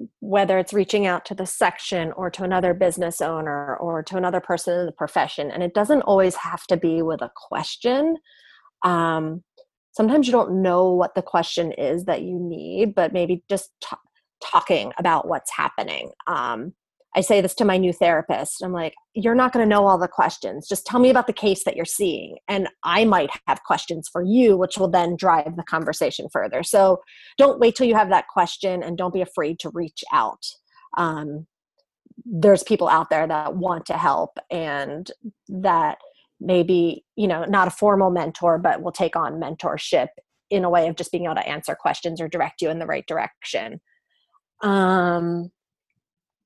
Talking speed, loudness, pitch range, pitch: 190 wpm, -21 LUFS, 170-210 Hz, 185 Hz